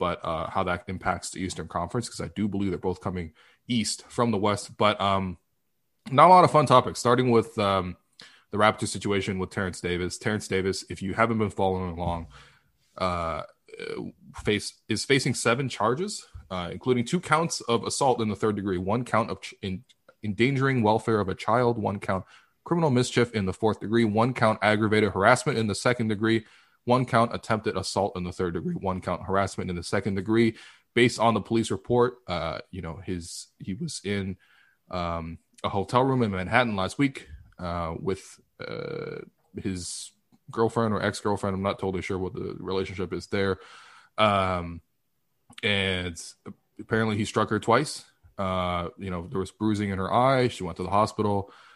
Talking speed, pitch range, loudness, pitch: 185 wpm, 95-115 Hz, -26 LUFS, 100 Hz